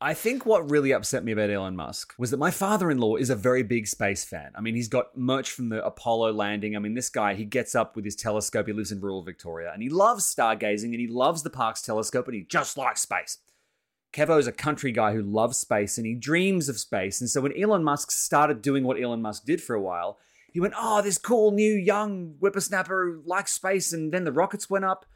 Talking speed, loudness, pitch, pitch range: 250 wpm, -26 LUFS, 125 Hz, 110-180 Hz